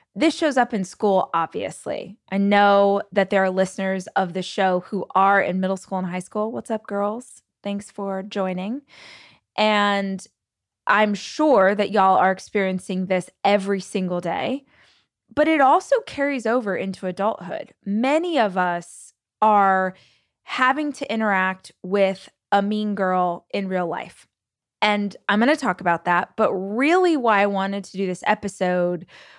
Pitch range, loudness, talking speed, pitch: 190-215 Hz, -21 LUFS, 155 wpm, 200 Hz